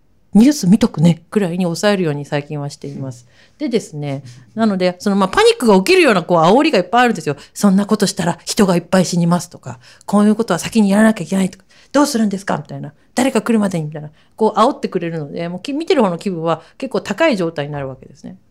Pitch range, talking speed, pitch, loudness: 160-220 Hz, 445 characters per minute, 185 Hz, -16 LUFS